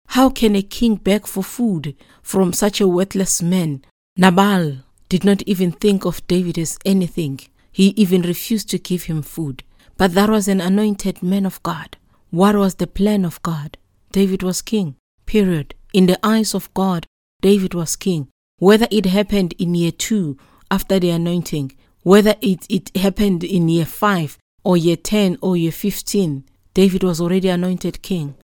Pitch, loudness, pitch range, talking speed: 185 Hz, -18 LUFS, 170-200 Hz, 170 wpm